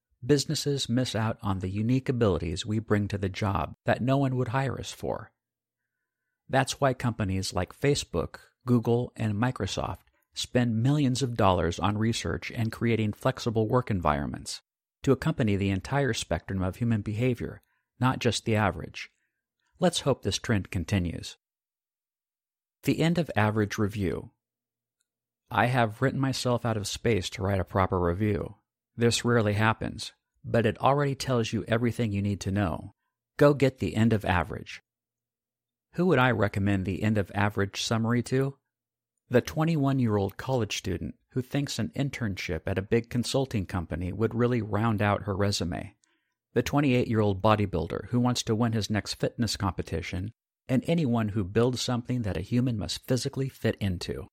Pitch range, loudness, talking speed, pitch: 100-125 Hz, -28 LUFS, 160 wpm, 115 Hz